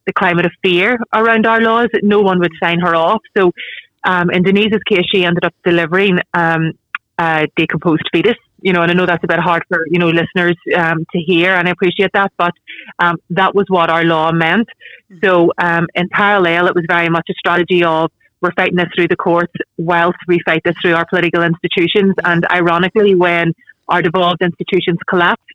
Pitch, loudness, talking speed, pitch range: 175 Hz, -13 LUFS, 205 wpm, 170-190 Hz